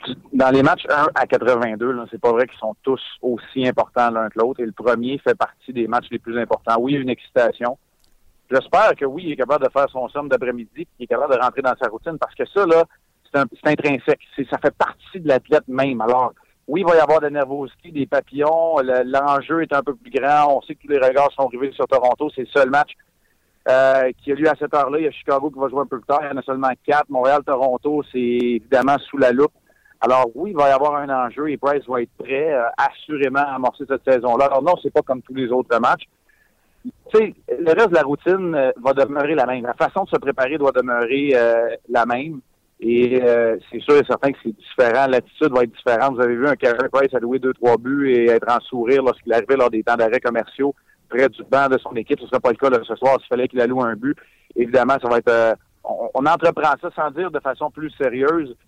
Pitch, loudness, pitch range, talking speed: 135 Hz, -19 LUFS, 125-145 Hz, 255 wpm